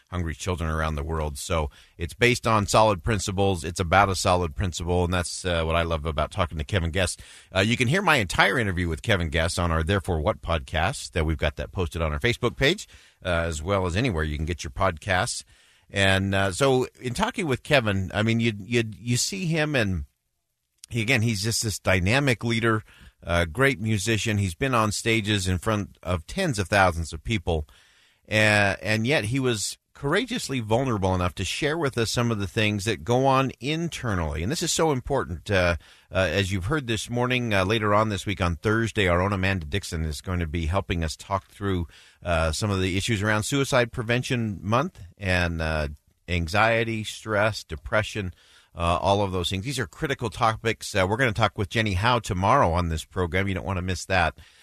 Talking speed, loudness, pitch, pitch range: 210 wpm, -25 LUFS, 100 Hz, 90-115 Hz